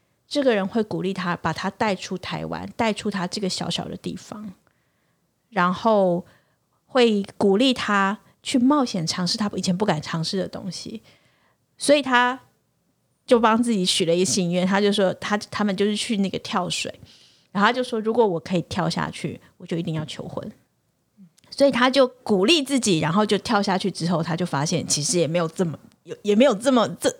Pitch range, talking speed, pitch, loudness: 180-225 Hz, 270 characters per minute, 200 Hz, -22 LUFS